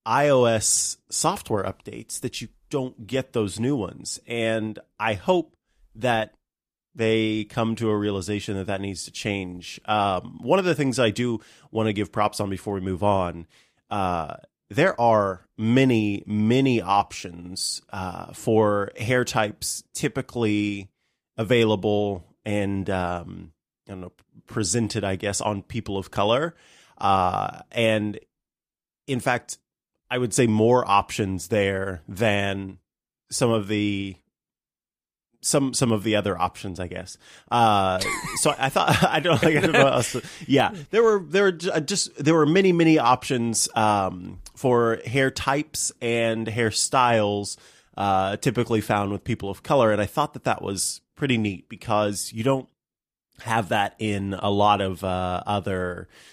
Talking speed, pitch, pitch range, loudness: 150 wpm, 110 Hz, 100-125 Hz, -23 LUFS